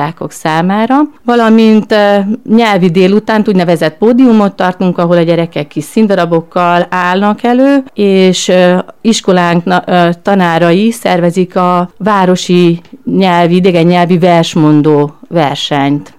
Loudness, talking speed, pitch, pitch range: -9 LUFS, 110 wpm, 180 Hz, 175-210 Hz